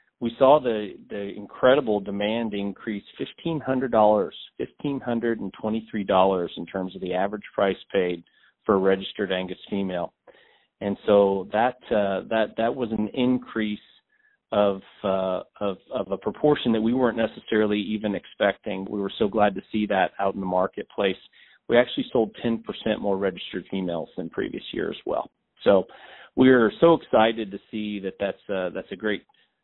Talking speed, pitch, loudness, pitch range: 175 wpm, 105 Hz, -25 LUFS, 95-115 Hz